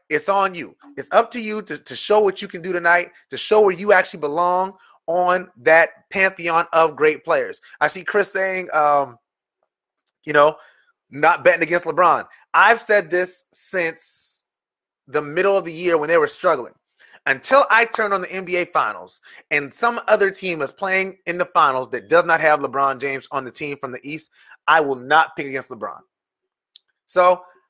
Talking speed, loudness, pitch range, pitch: 185 wpm, -19 LUFS, 155-195 Hz, 180 Hz